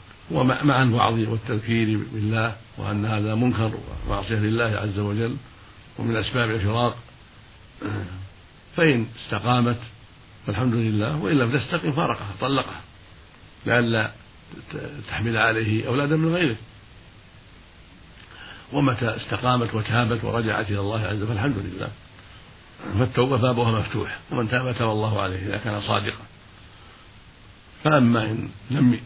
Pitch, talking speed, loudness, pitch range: 110 Hz, 110 wpm, -23 LUFS, 105-125 Hz